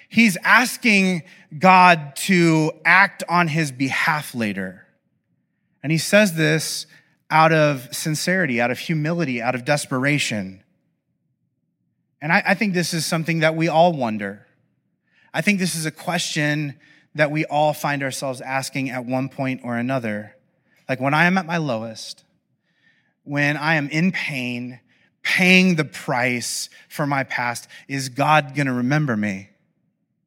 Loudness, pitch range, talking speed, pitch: -19 LUFS, 130-170 Hz, 145 wpm, 150 Hz